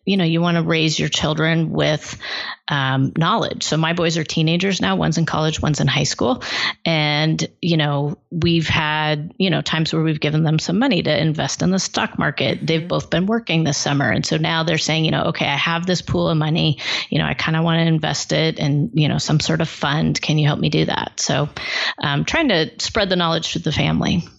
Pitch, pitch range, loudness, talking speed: 160 Hz, 150-165 Hz, -19 LUFS, 235 wpm